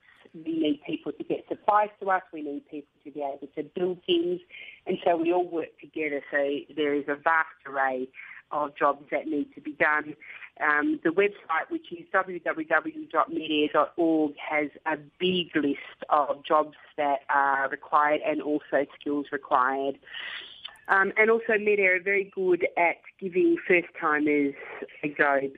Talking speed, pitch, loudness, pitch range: 155 wpm, 155 Hz, -27 LUFS, 145-185 Hz